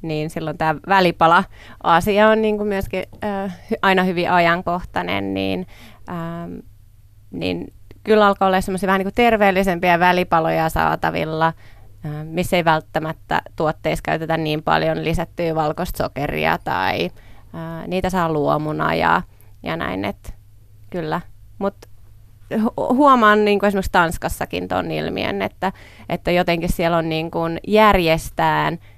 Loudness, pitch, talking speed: -19 LUFS, 165 Hz, 120 wpm